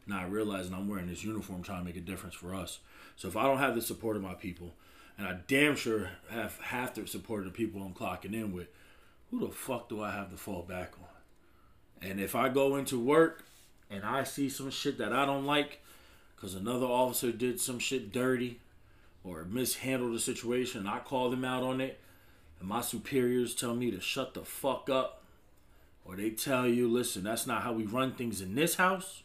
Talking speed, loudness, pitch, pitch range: 215 wpm, -33 LUFS, 115 Hz, 95-125 Hz